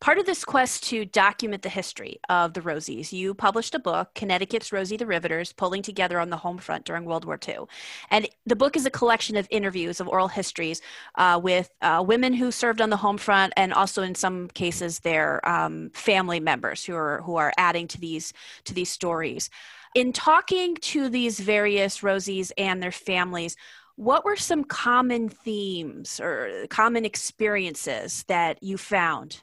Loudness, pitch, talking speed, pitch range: -25 LUFS, 195 Hz, 180 wpm, 175-225 Hz